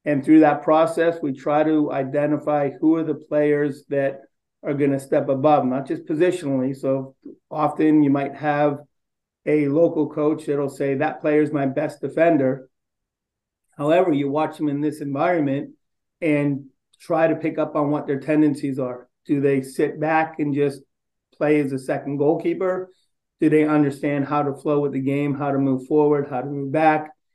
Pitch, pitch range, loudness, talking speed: 145 Hz, 140-155 Hz, -21 LUFS, 180 wpm